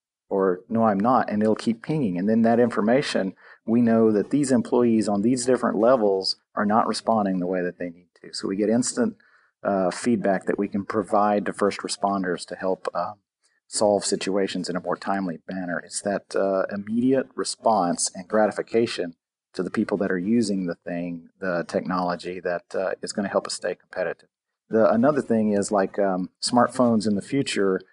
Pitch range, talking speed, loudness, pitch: 95-115 Hz, 190 wpm, -24 LUFS, 100 Hz